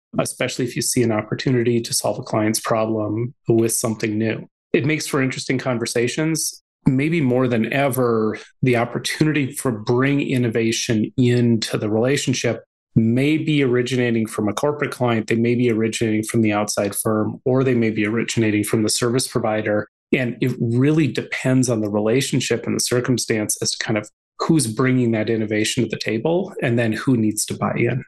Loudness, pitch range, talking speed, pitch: -20 LUFS, 110-130 Hz, 175 wpm, 120 Hz